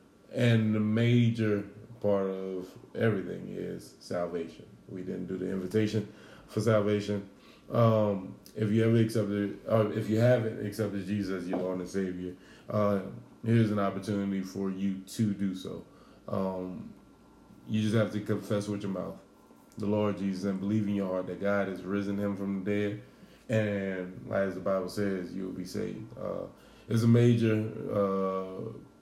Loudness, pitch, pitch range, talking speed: -31 LUFS, 100 Hz, 95-110 Hz, 160 wpm